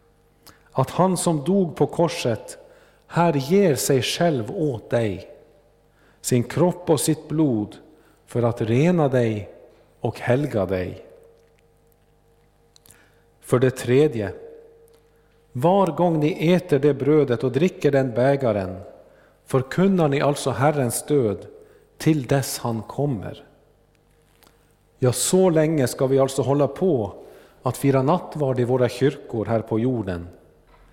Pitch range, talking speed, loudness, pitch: 125-170 Hz, 120 wpm, -22 LUFS, 140 Hz